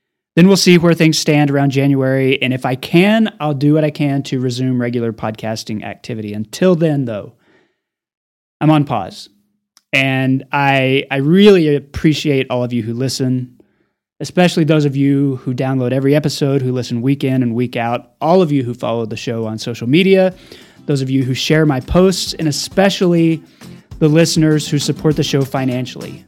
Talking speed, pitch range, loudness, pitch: 180 wpm, 125-160 Hz, -15 LUFS, 140 Hz